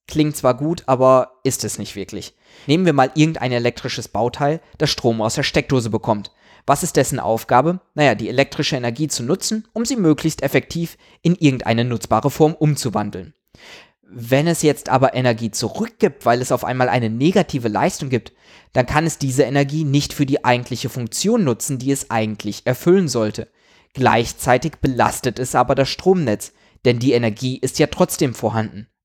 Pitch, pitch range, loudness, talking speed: 130 Hz, 120-155 Hz, -19 LUFS, 170 wpm